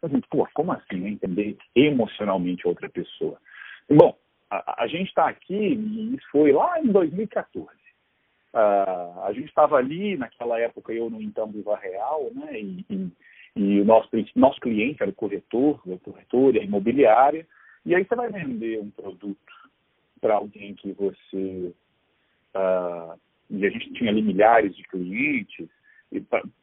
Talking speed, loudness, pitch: 155 wpm, -23 LUFS, 115 Hz